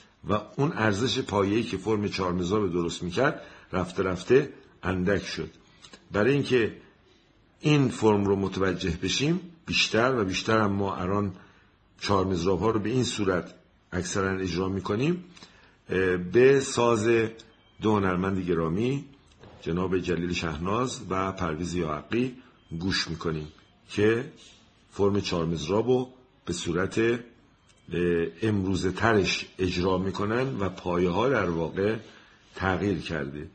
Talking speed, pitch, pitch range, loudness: 115 wpm, 95 Hz, 90-115 Hz, -27 LUFS